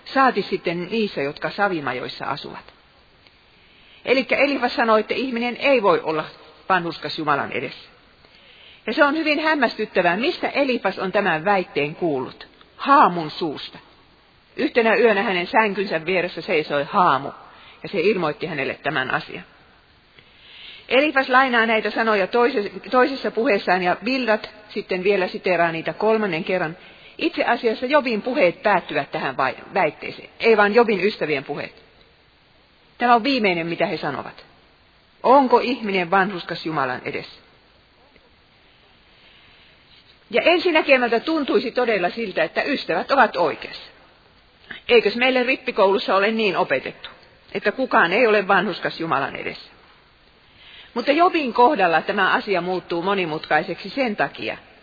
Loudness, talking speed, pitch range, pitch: -20 LUFS, 120 wpm, 185-250 Hz, 215 Hz